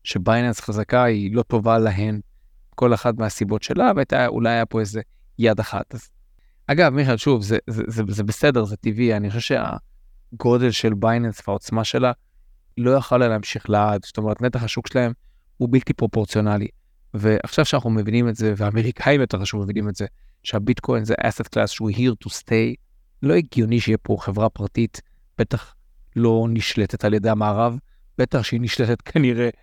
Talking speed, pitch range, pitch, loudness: 165 wpm, 105-120 Hz, 115 Hz, -21 LUFS